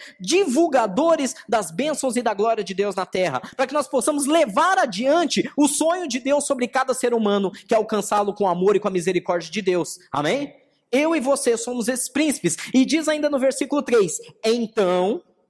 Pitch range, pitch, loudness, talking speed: 205-290 Hz, 250 Hz, -21 LUFS, 195 wpm